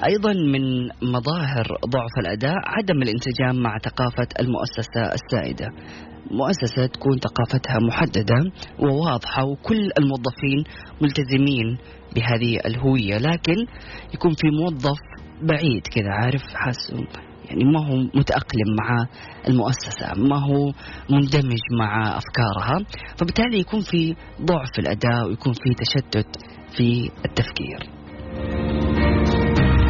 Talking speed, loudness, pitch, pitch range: 100 wpm, -22 LUFS, 125 Hz, 115-145 Hz